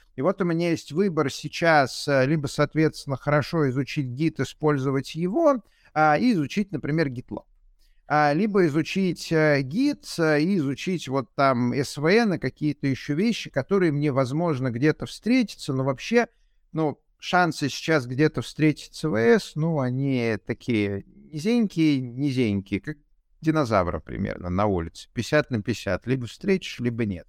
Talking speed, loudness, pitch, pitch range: 140 wpm, -24 LUFS, 150 Hz, 130-165 Hz